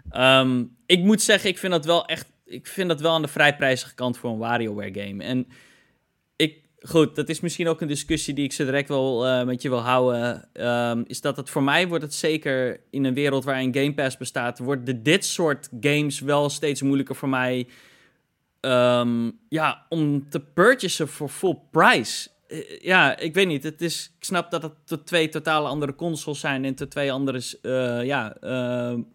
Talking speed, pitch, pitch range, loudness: 200 wpm, 140 Hz, 125-160 Hz, -23 LUFS